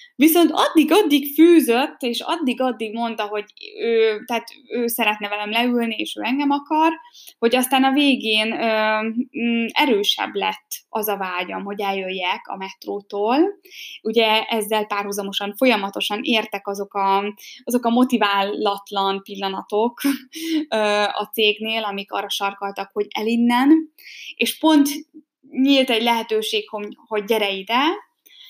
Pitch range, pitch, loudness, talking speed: 205-280 Hz, 230 Hz, -20 LUFS, 125 wpm